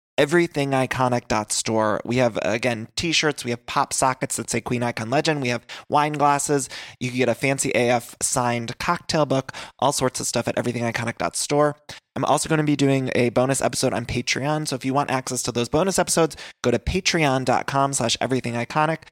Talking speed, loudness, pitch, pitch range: 175 wpm, -22 LUFS, 130 Hz, 120-145 Hz